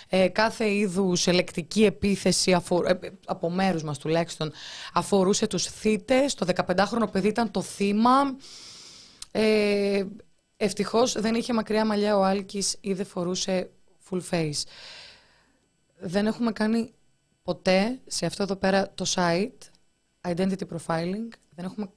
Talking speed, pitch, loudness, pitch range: 130 wpm, 195 Hz, -25 LUFS, 180-215 Hz